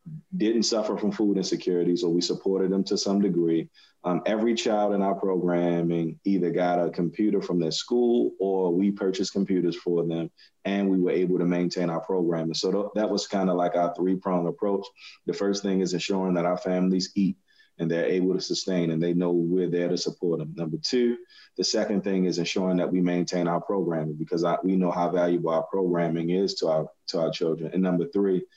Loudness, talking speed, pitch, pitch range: -26 LUFS, 215 wpm, 90 Hz, 85-100 Hz